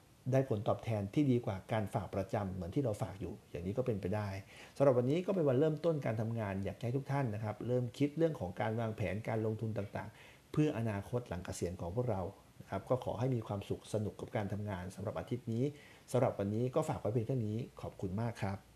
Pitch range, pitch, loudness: 100-130 Hz, 110 Hz, -37 LUFS